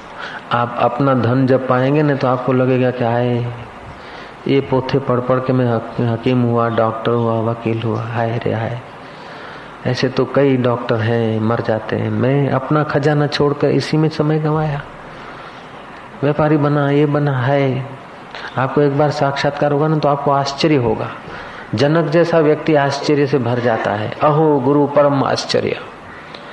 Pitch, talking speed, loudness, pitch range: 135 Hz, 155 wpm, -16 LUFS, 120-145 Hz